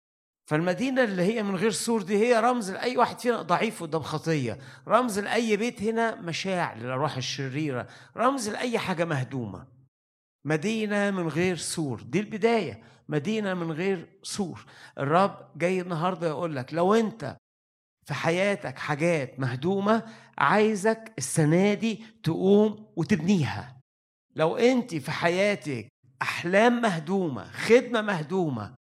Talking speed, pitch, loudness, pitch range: 125 wpm, 175 Hz, -26 LUFS, 145-215 Hz